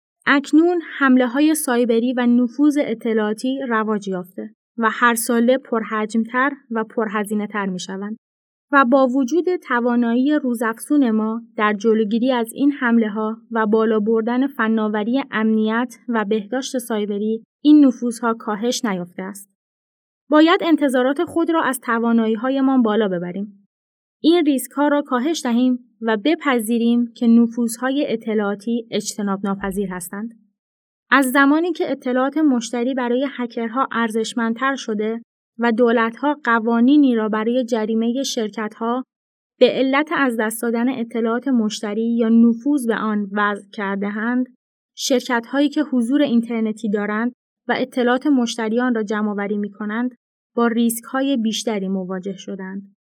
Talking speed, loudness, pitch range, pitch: 130 wpm, -19 LUFS, 220-260 Hz, 235 Hz